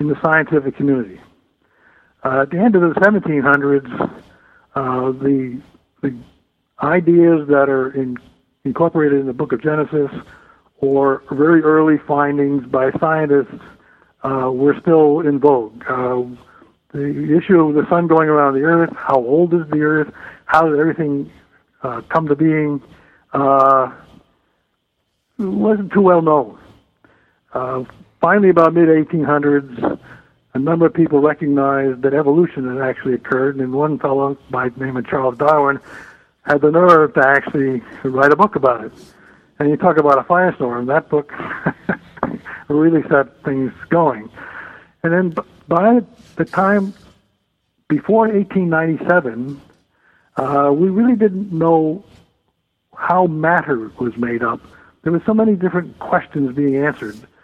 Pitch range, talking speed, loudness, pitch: 135-165 Hz, 140 wpm, -16 LUFS, 150 Hz